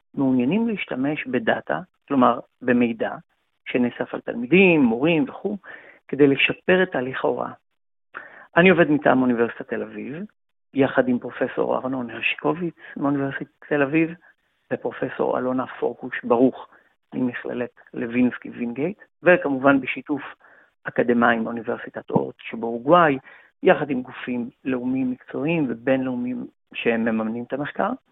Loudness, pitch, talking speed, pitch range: -22 LUFS, 135 Hz, 115 wpm, 125-170 Hz